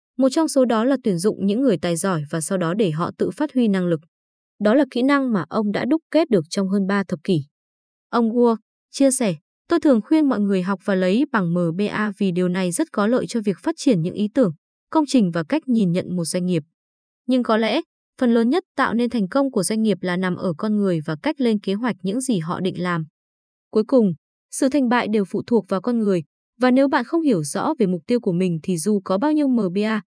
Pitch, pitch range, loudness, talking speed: 215 Hz, 185-255 Hz, -21 LUFS, 255 wpm